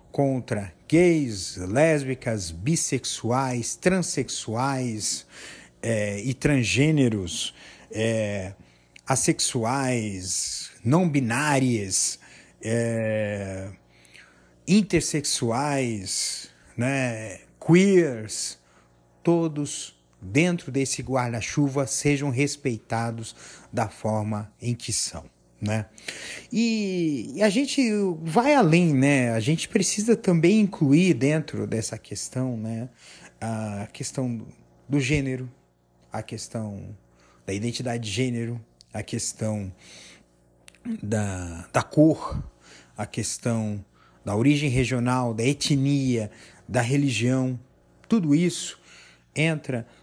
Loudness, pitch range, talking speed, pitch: -25 LUFS, 105-145 Hz, 85 wpm, 120 Hz